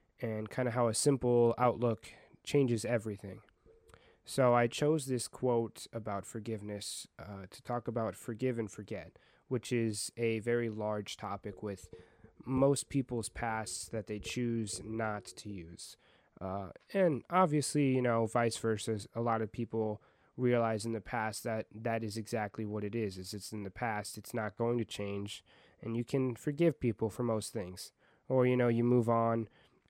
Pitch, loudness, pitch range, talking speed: 115 Hz, -34 LUFS, 105-120 Hz, 170 wpm